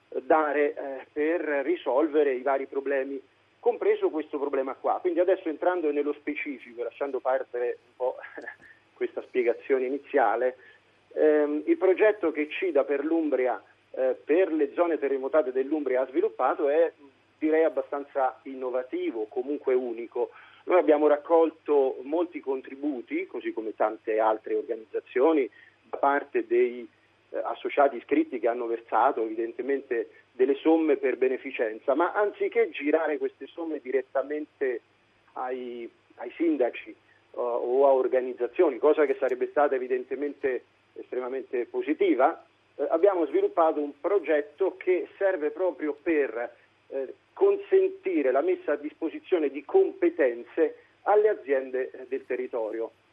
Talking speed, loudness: 120 wpm, -27 LUFS